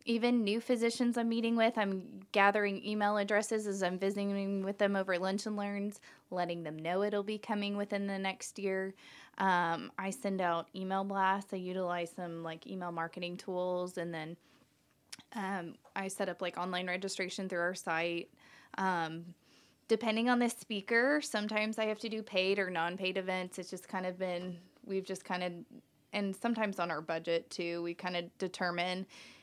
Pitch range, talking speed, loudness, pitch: 180-205 Hz, 180 wpm, -35 LUFS, 190 Hz